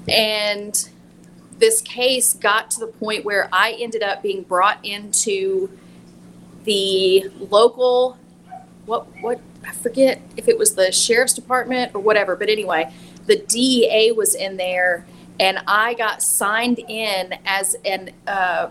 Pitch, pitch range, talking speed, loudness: 215 Hz, 190-245 Hz, 140 wpm, -18 LUFS